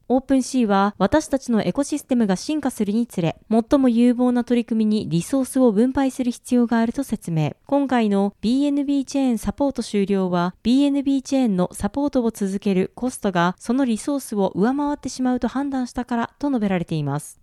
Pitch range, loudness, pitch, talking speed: 200-270 Hz, -21 LUFS, 240 Hz, 405 characters per minute